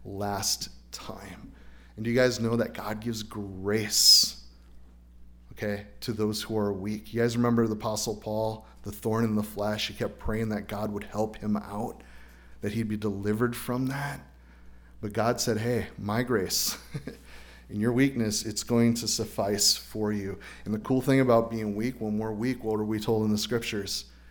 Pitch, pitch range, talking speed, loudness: 105 Hz, 100-115 Hz, 185 wpm, -28 LUFS